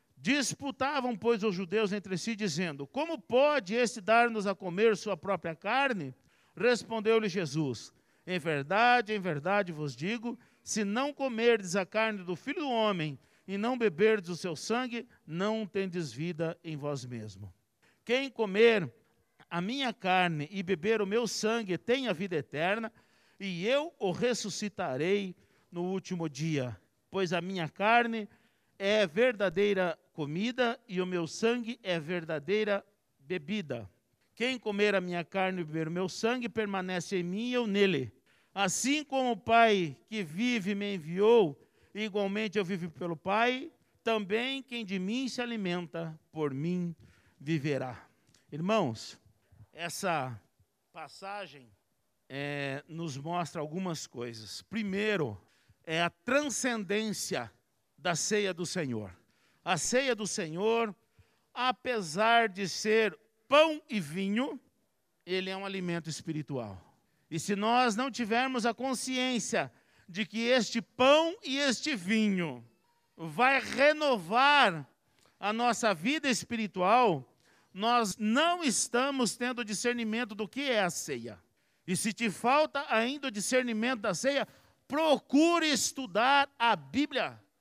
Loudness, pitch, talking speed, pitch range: -31 LUFS, 205 Hz, 130 wpm, 170-235 Hz